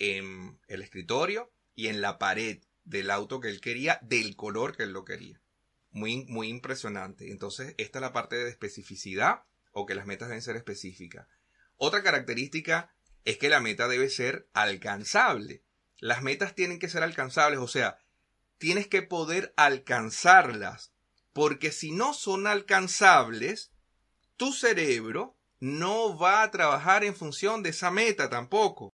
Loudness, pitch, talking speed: -27 LUFS, 150 Hz, 150 wpm